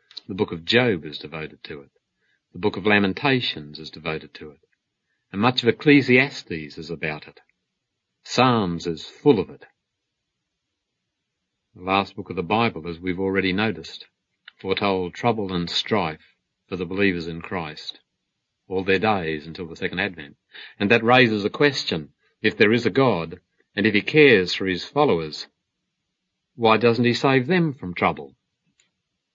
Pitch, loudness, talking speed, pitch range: 95 Hz, -21 LUFS, 160 wpm, 85-115 Hz